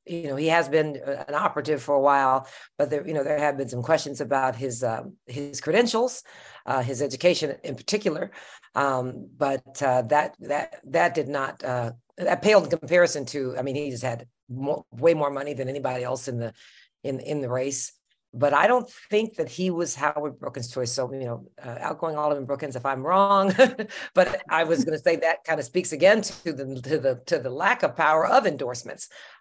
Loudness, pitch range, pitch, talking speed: -25 LUFS, 135-165 Hz, 145 Hz, 210 wpm